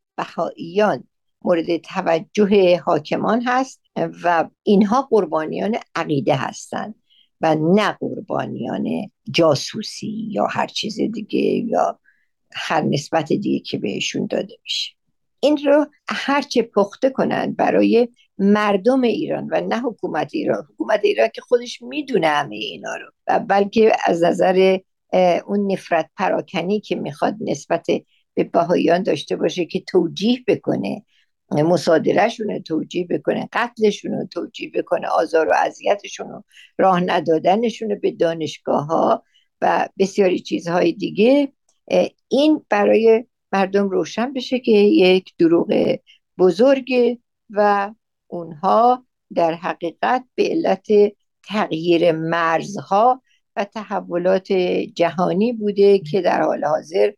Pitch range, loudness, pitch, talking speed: 175-235 Hz, -19 LUFS, 200 Hz, 110 wpm